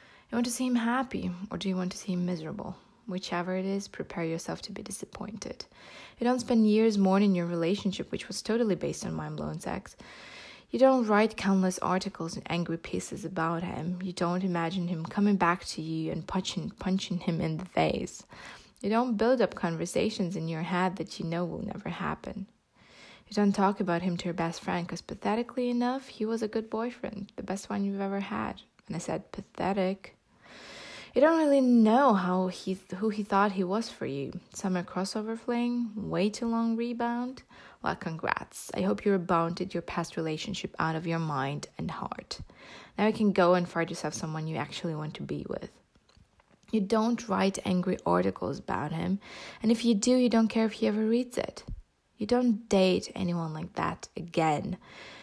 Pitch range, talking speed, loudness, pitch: 175-220 Hz, 195 wpm, -30 LUFS, 190 Hz